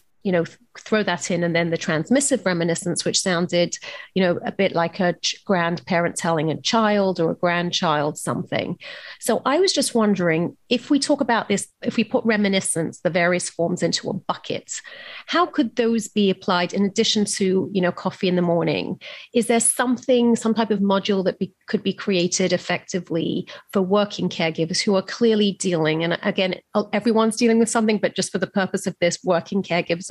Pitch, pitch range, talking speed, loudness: 190 Hz, 175-225 Hz, 195 wpm, -21 LUFS